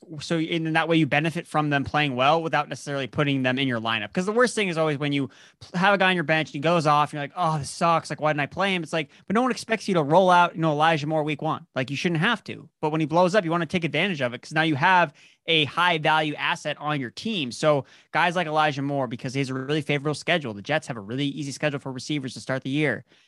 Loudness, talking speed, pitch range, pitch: -24 LUFS, 295 wpm, 140-170 Hz, 155 Hz